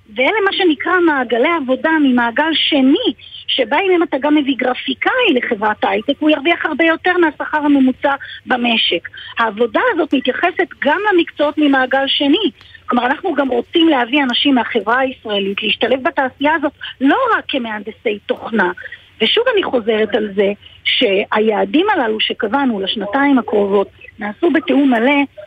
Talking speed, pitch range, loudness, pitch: 135 wpm, 240-315 Hz, -15 LUFS, 275 Hz